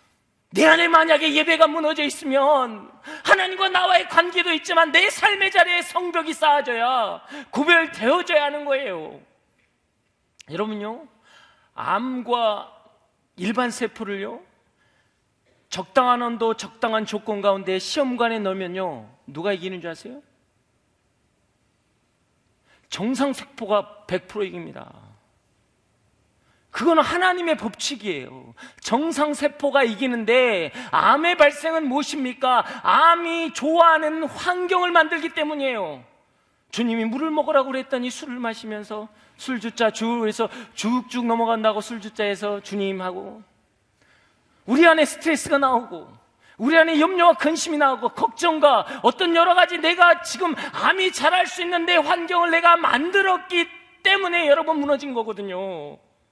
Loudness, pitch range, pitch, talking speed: -20 LUFS, 220-330 Hz, 275 Hz, 275 characters per minute